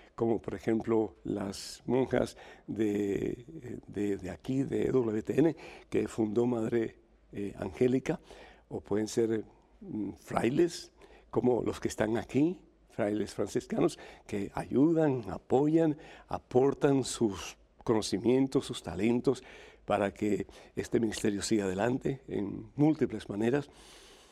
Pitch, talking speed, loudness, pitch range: 115 Hz, 110 wpm, -32 LUFS, 105-130 Hz